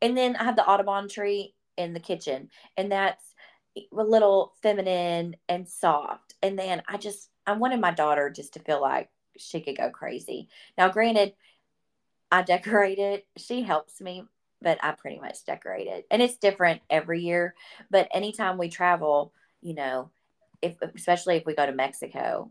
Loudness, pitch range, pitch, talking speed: -26 LUFS, 170-200 Hz, 185 Hz, 175 wpm